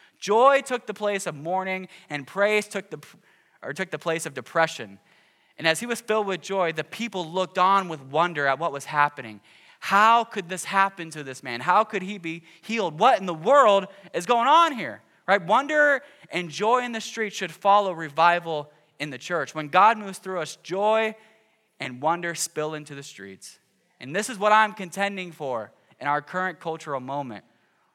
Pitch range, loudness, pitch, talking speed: 155-210 Hz, -24 LUFS, 185 Hz, 195 wpm